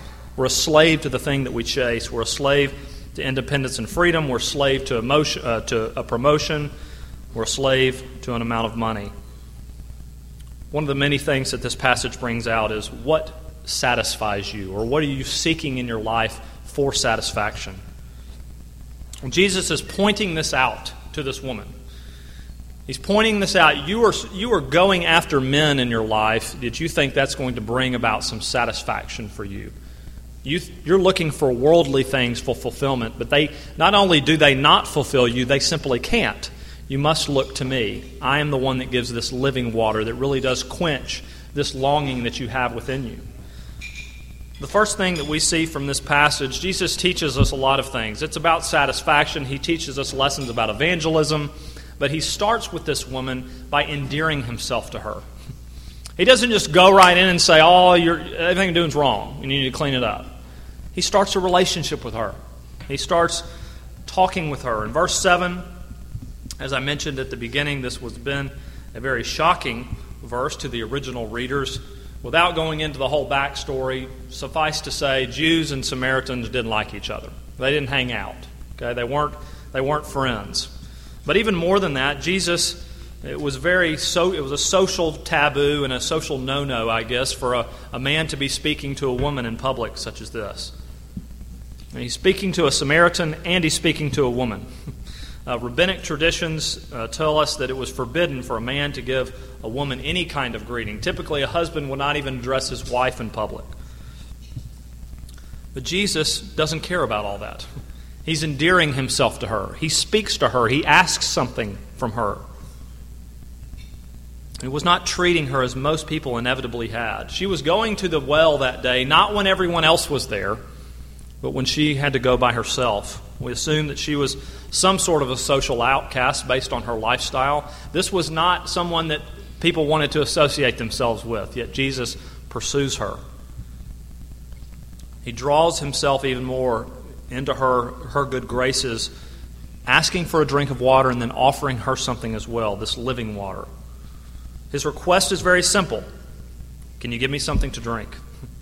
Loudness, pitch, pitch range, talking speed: -20 LUFS, 130 Hz, 110-155 Hz, 180 wpm